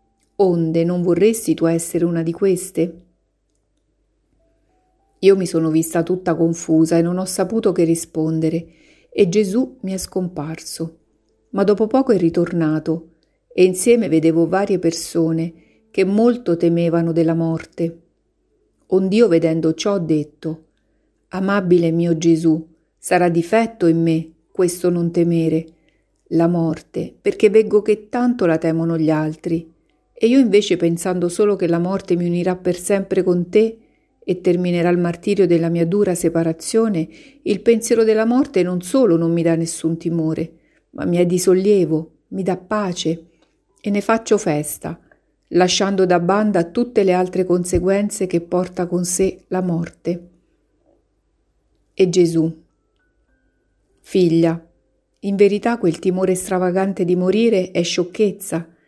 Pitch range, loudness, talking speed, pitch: 165-195 Hz, -18 LUFS, 135 wpm, 175 Hz